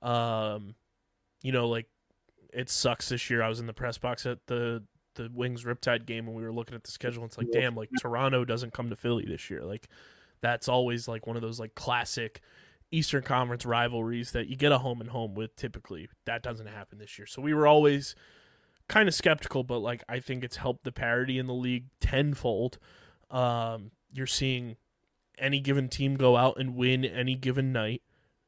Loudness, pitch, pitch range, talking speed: -30 LUFS, 120 Hz, 115-130 Hz, 205 wpm